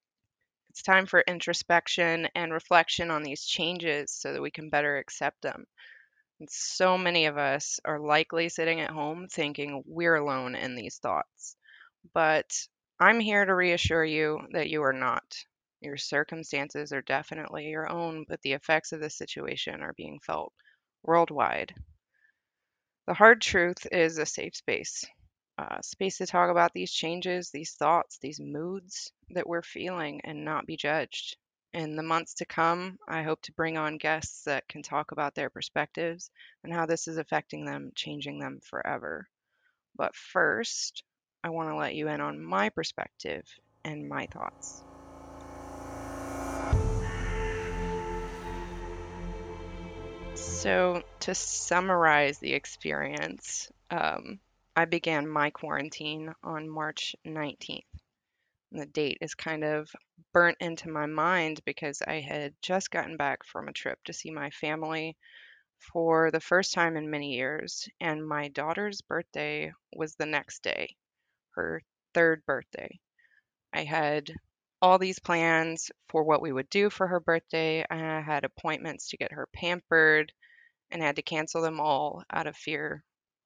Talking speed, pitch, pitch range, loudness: 145 wpm, 160 Hz, 145-170 Hz, -29 LUFS